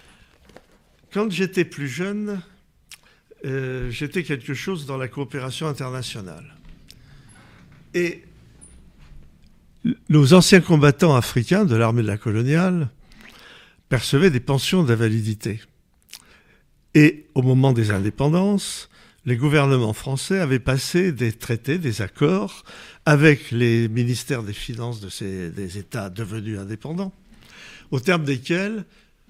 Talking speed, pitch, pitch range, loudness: 110 wpm, 135 Hz, 115-175 Hz, -21 LUFS